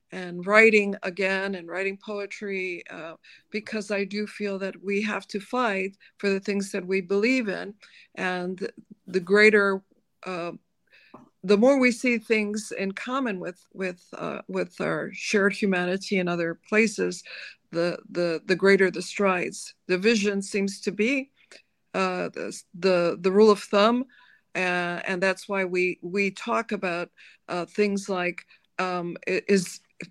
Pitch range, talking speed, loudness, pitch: 185-210 Hz, 150 wpm, -25 LUFS, 195 Hz